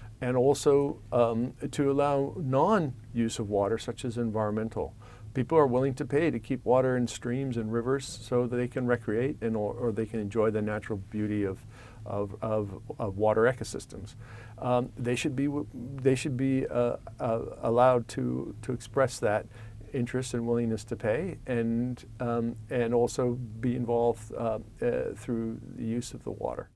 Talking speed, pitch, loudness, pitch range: 170 wpm, 120 Hz, -30 LUFS, 110-125 Hz